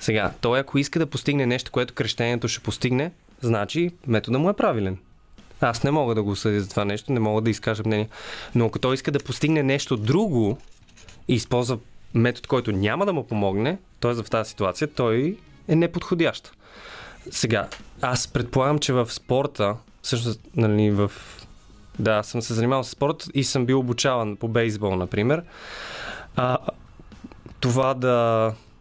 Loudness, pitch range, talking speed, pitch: -24 LUFS, 110-135 Hz, 160 wpm, 120 Hz